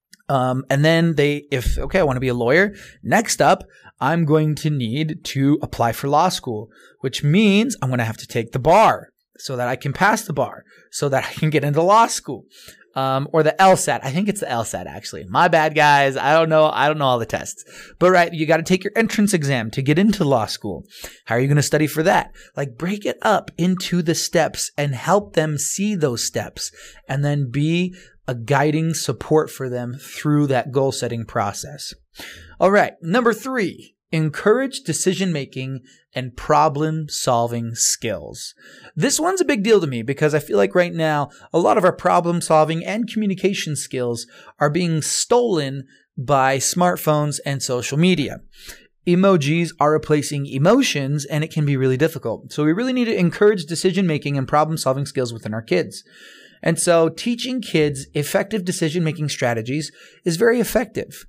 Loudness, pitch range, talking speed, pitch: -19 LUFS, 135-175 Hz, 190 wpm, 150 Hz